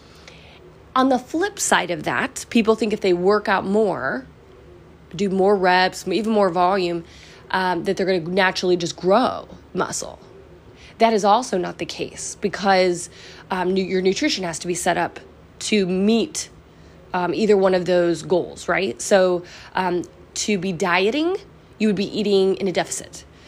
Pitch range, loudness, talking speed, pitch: 180-205 Hz, -21 LUFS, 160 wpm, 190 Hz